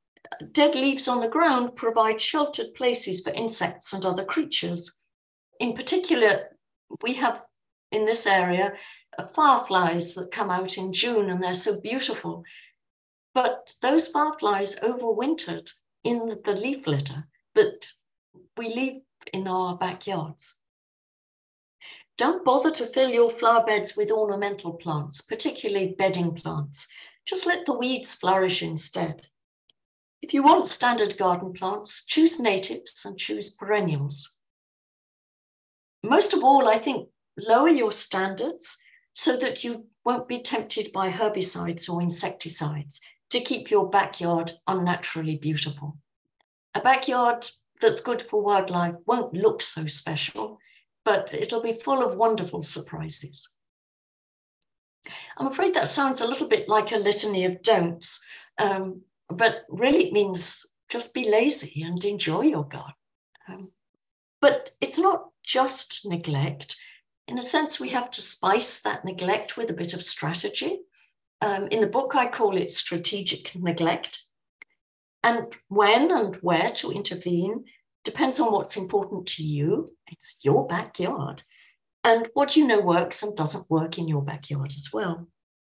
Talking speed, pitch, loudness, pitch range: 135 wpm, 210 Hz, -25 LUFS, 175-250 Hz